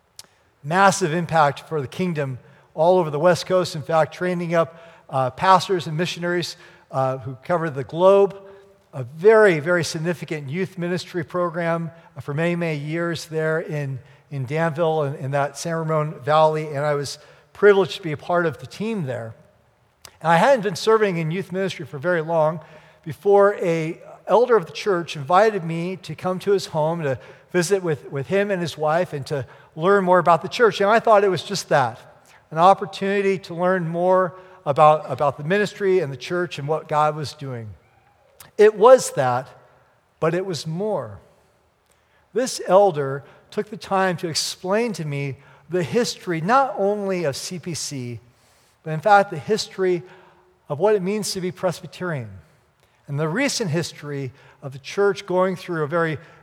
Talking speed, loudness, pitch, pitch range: 175 wpm, -21 LUFS, 170 Hz, 150-190 Hz